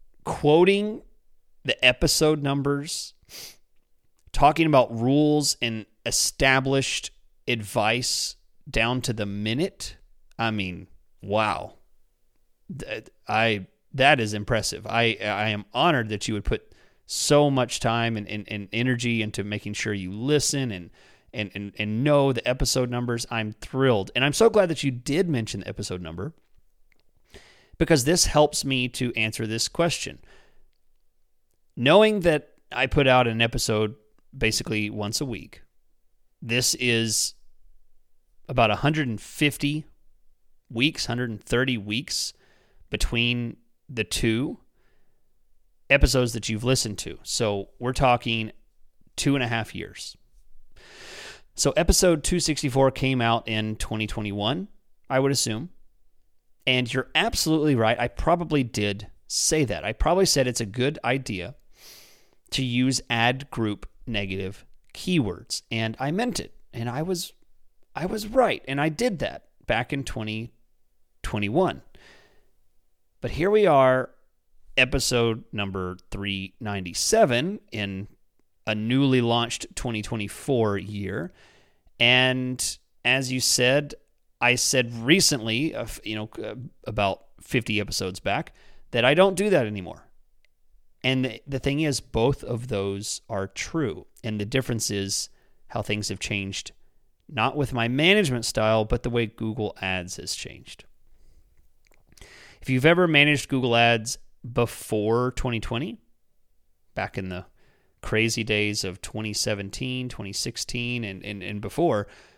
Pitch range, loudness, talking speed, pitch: 105-135 Hz, -24 LUFS, 130 wpm, 115 Hz